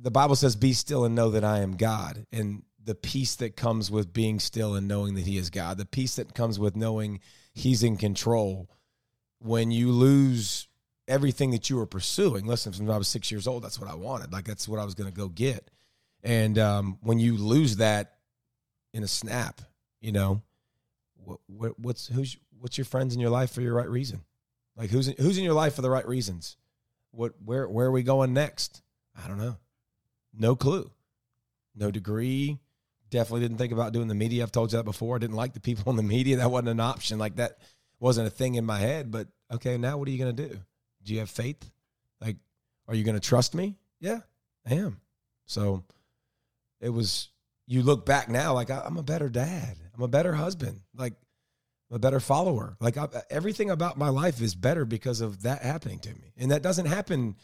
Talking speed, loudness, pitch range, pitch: 215 wpm, -28 LUFS, 110-130 Hz, 120 Hz